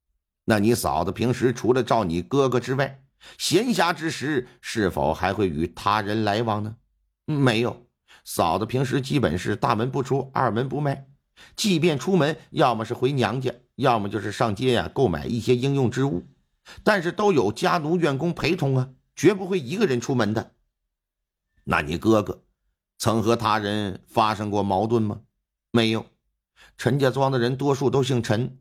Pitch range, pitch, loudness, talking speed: 110-140 Hz, 125 Hz, -23 LUFS, 245 characters per minute